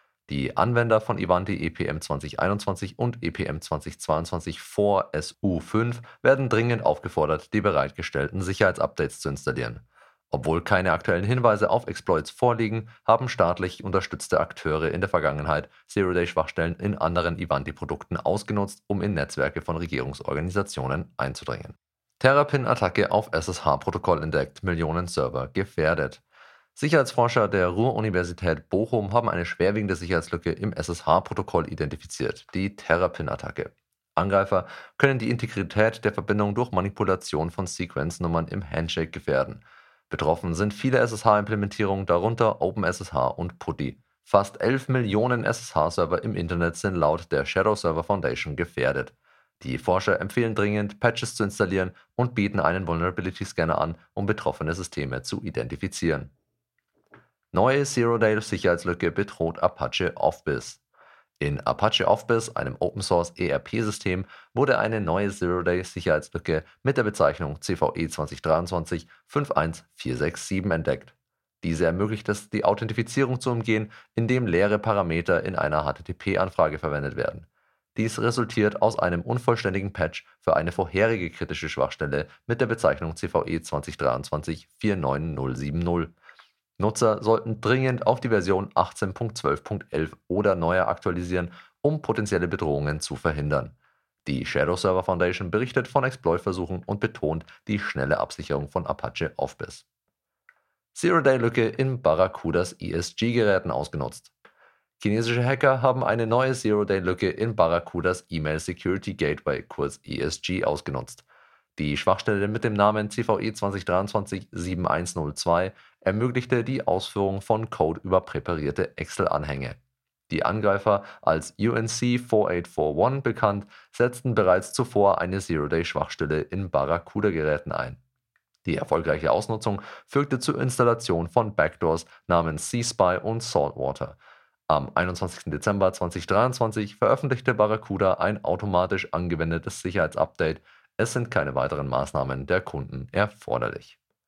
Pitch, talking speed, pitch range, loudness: 95 Hz, 115 wpm, 85-110 Hz, -25 LUFS